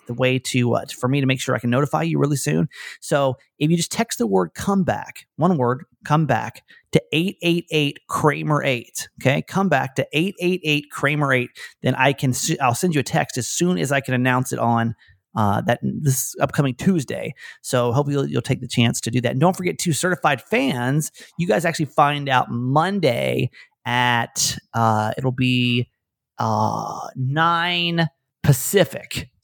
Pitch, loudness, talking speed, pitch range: 140 Hz, -21 LUFS, 180 wpm, 125-165 Hz